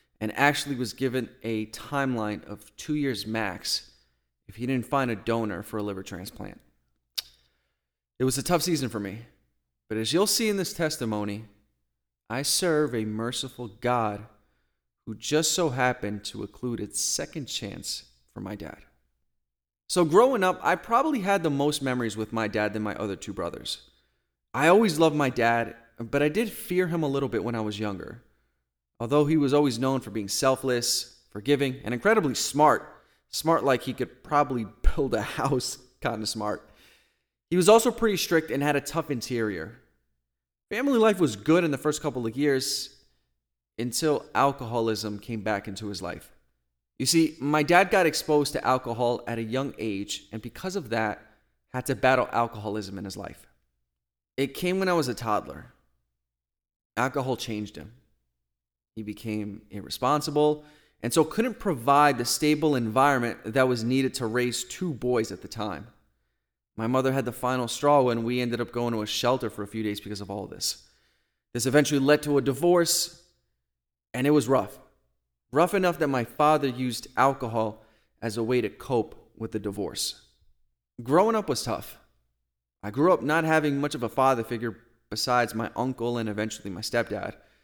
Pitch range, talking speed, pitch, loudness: 100-140 Hz, 175 wpm, 120 Hz, -26 LUFS